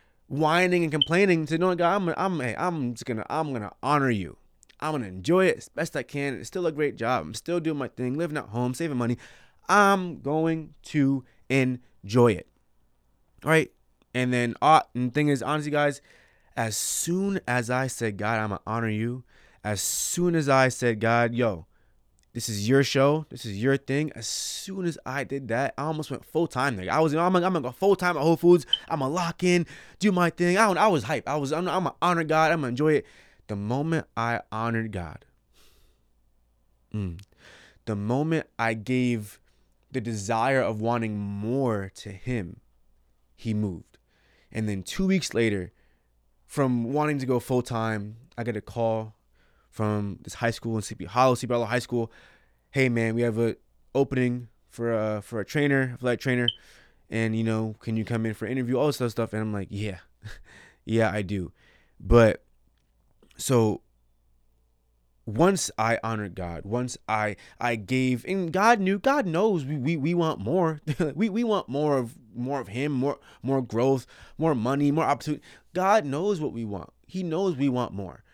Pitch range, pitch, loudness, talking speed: 110-150 Hz, 125 Hz, -26 LUFS, 195 wpm